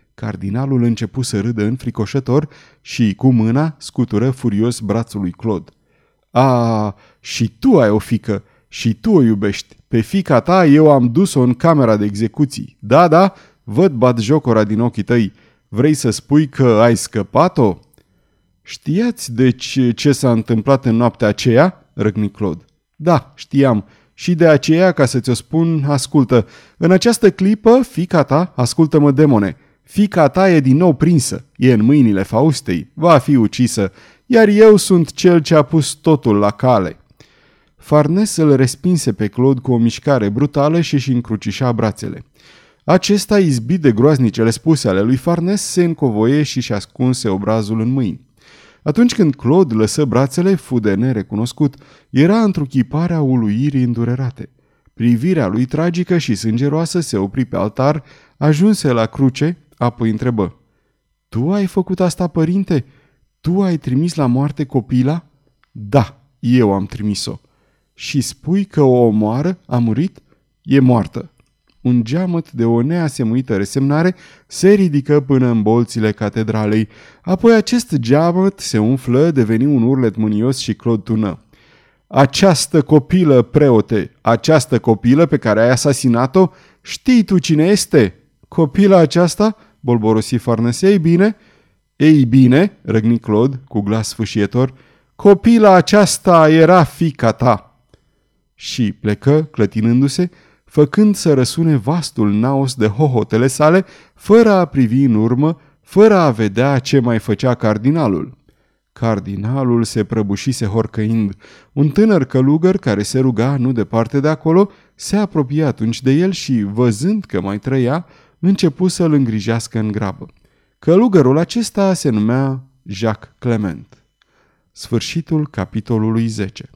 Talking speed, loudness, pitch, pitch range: 140 wpm, -14 LUFS, 130 Hz, 115-160 Hz